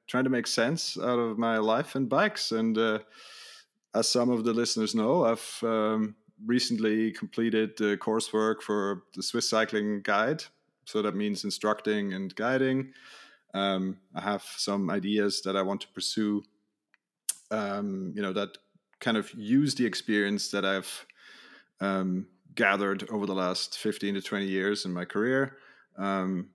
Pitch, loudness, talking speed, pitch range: 105 Hz, -29 LUFS, 155 wpm, 100-115 Hz